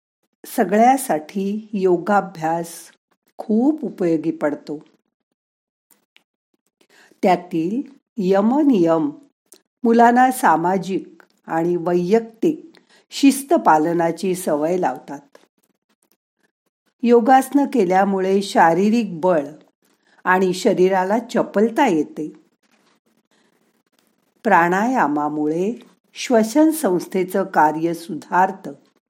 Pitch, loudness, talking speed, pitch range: 195 Hz, -18 LUFS, 60 wpm, 170-235 Hz